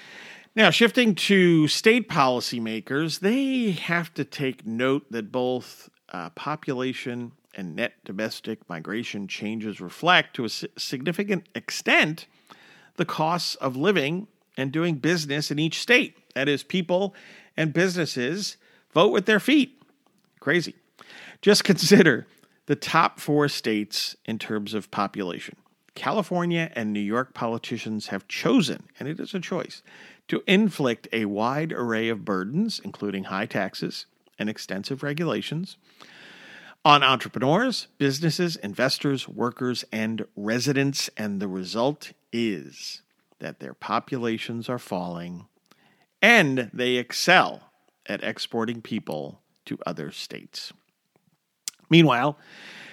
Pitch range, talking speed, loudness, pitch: 110-175 Hz, 120 wpm, -24 LUFS, 135 Hz